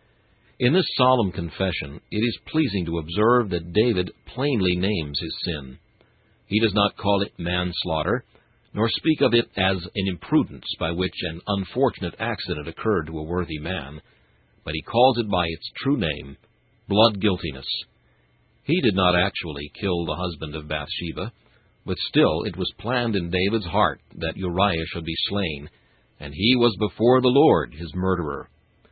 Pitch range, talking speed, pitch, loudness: 85-110 Hz, 160 wpm, 95 Hz, -23 LUFS